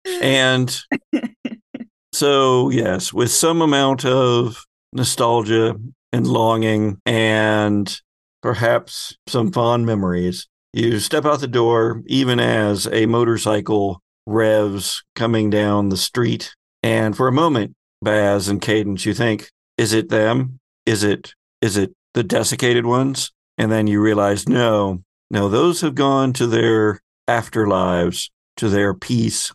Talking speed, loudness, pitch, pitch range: 130 wpm, -18 LUFS, 115 Hz, 105-130 Hz